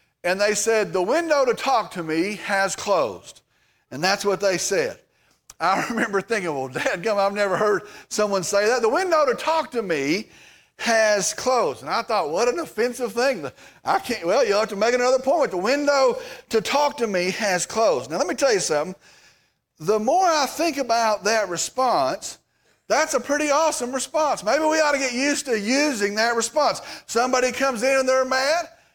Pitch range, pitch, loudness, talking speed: 205-290 Hz, 240 Hz, -22 LUFS, 195 wpm